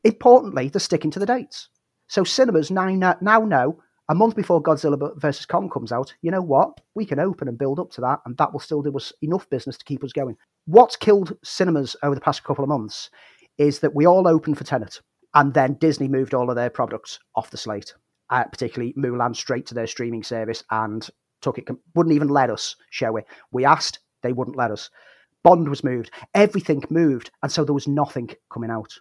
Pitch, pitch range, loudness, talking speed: 145 Hz, 130-175 Hz, -21 LUFS, 215 wpm